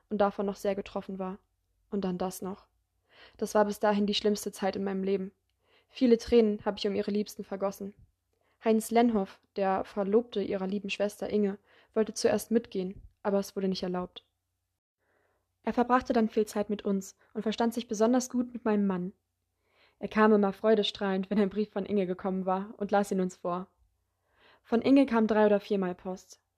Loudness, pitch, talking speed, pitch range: -30 LUFS, 205 Hz, 185 wpm, 195-220 Hz